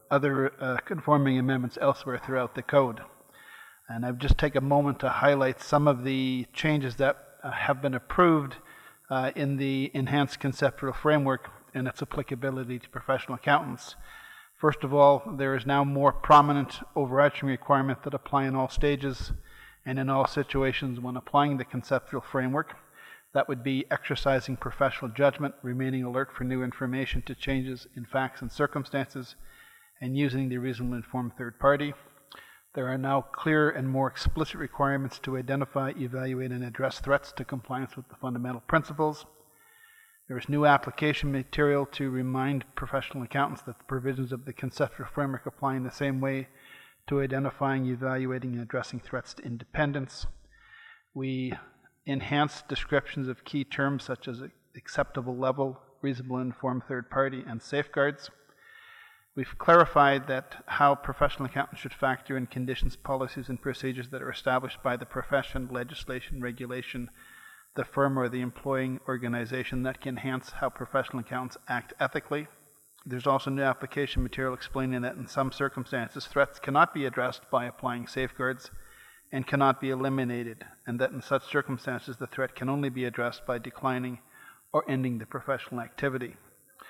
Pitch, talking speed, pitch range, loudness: 135 Hz, 155 wpm, 130-140 Hz, -29 LUFS